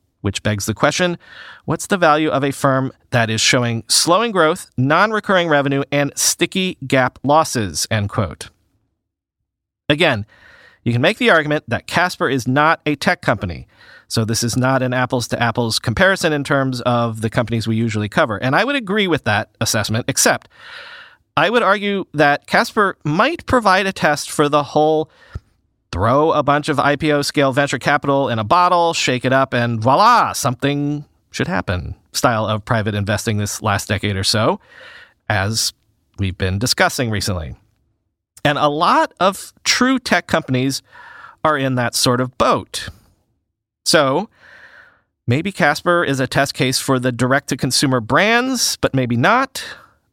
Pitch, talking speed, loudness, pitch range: 130 Hz, 165 wpm, -17 LUFS, 110-155 Hz